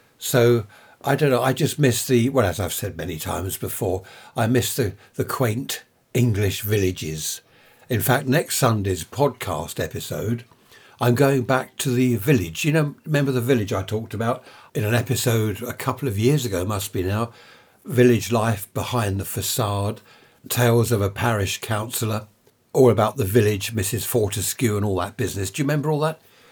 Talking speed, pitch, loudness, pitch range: 175 wpm, 120 Hz, -22 LUFS, 105-130 Hz